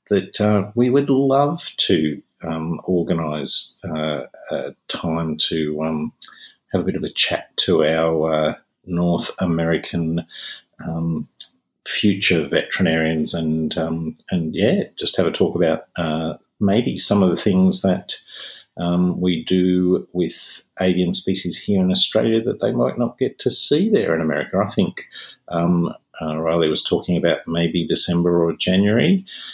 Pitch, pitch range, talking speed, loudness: 85 Hz, 80-95 Hz, 150 wpm, -19 LUFS